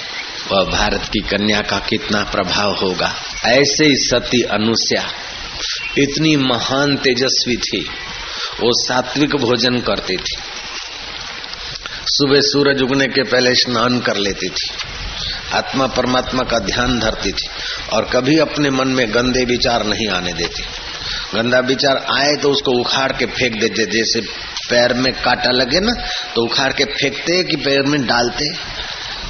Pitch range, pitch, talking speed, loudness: 115-140 Hz, 125 Hz, 140 wpm, -16 LUFS